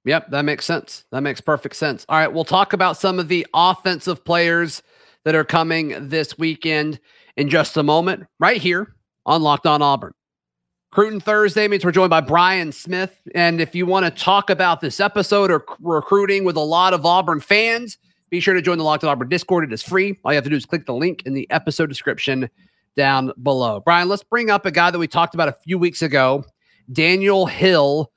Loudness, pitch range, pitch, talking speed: -18 LUFS, 150-185 Hz, 170 Hz, 215 wpm